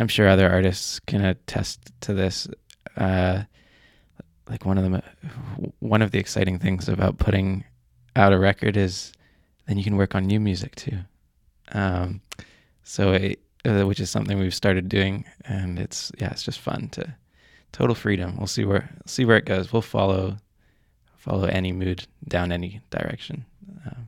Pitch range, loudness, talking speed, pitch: 95-105 Hz, -24 LUFS, 165 wpm, 95 Hz